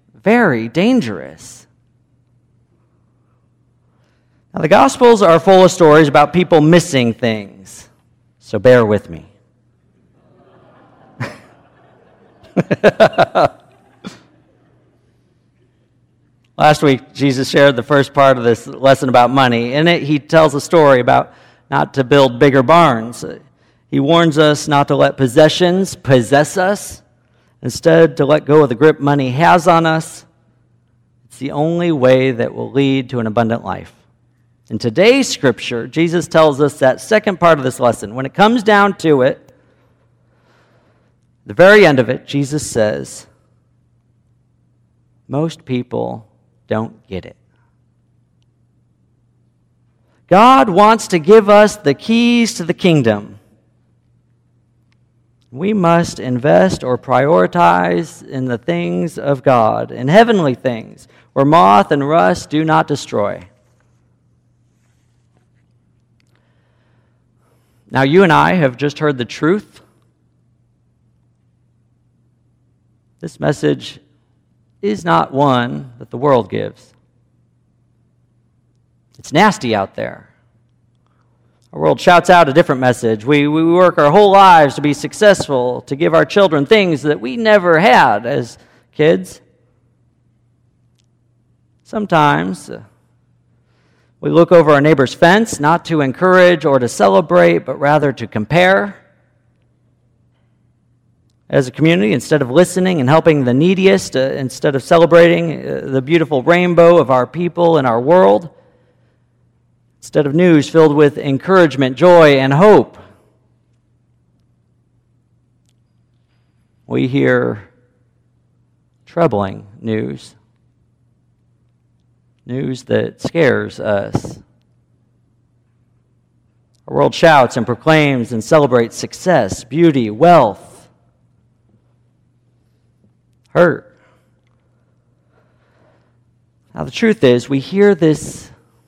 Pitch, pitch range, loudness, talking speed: 125 Hz, 120-155 Hz, -12 LUFS, 110 wpm